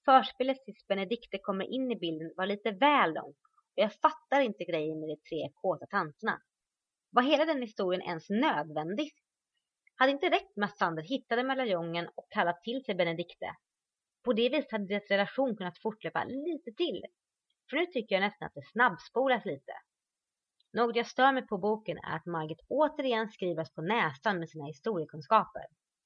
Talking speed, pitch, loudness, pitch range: 175 wpm, 215 Hz, -32 LUFS, 175-260 Hz